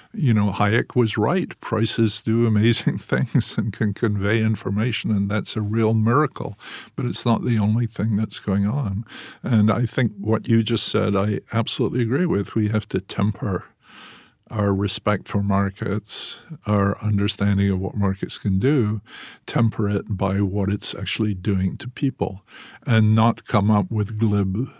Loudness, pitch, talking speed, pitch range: -22 LUFS, 105 Hz, 165 wpm, 100-115 Hz